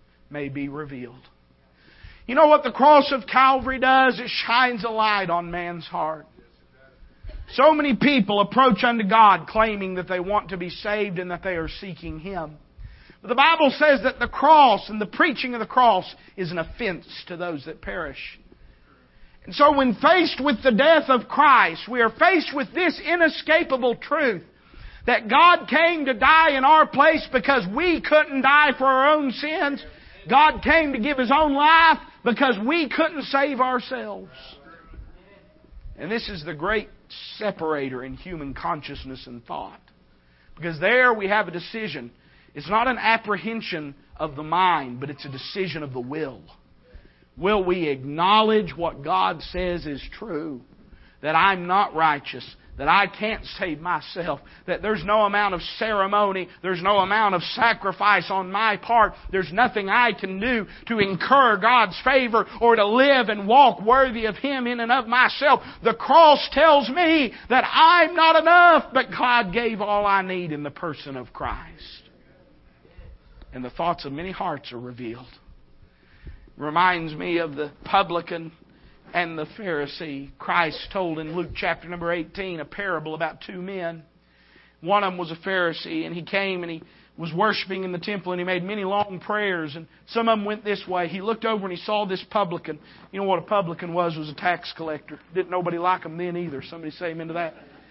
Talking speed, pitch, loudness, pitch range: 180 wpm, 195 Hz, -21 LUFS, 165-250 Hz